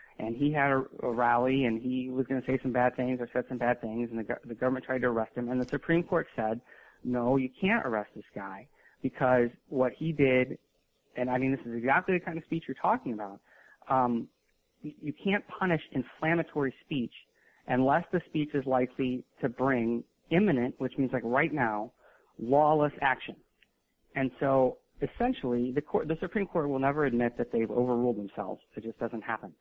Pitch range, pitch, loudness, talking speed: 120-150 Hz, 130 Hz, -30 LUFS, 190 wpm